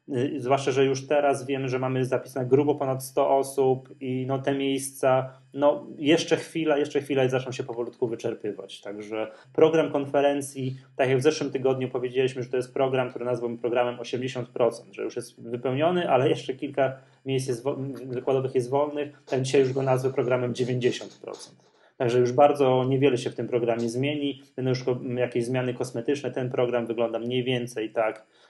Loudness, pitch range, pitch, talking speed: -26 LUFS, 125-140 Hz, 130 Hz, 175 wpm